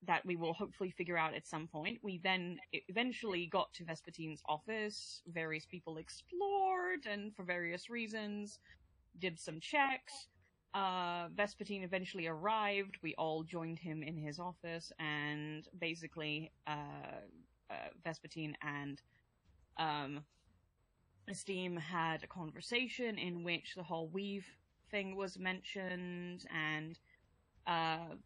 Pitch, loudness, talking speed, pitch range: 175 Hz, -41 LUFS, 125 wpm, 160-195 Hz